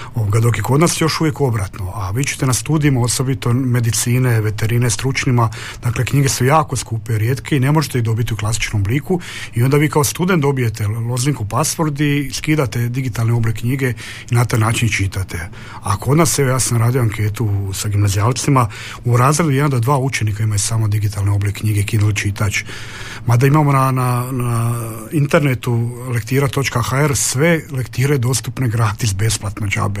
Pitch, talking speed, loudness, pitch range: 120 Hz, 170 wpm, -17 LUFS, 110-135 Hz